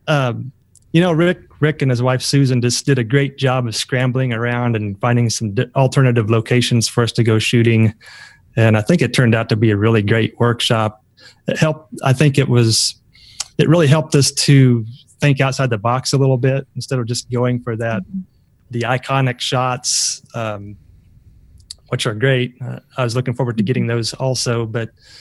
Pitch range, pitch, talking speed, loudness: 115-135 Hz, 125 Hz, 195 wpm, -16 LUFS